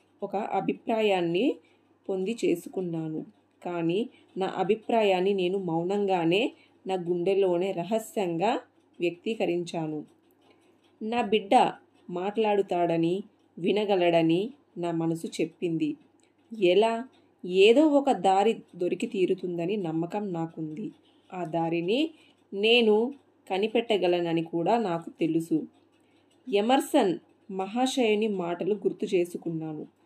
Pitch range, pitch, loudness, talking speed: 175-265 Hz, 200 Hz, -27 LUFS, 80 wpm